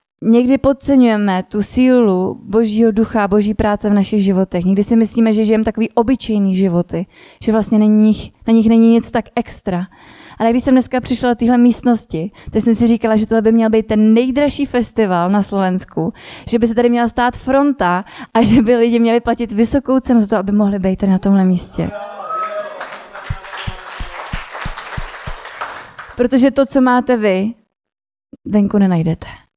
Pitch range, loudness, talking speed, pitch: 205-245 Hz, -14 LUFS, 165 wpm, 225 Hz